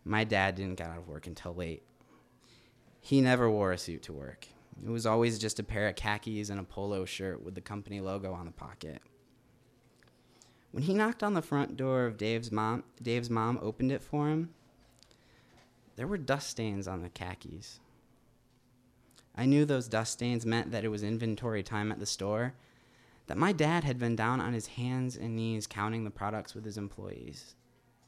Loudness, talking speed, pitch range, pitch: -33 LUFS, 190 wpm, 105-125 Hz, 115 Hz